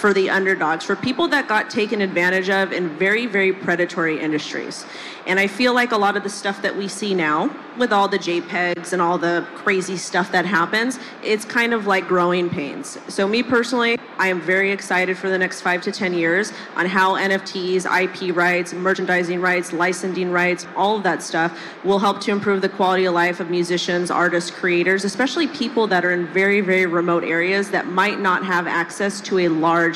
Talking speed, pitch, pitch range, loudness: 200 wpm, 185 Hz, 175-200 Hz, -19 LUFS